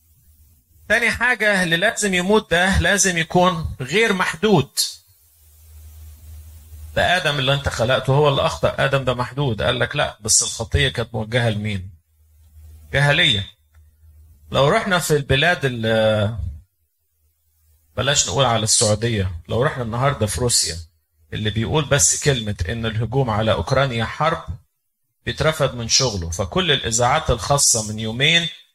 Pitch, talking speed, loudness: 115 Hz, 125 wpm, -18 LUFS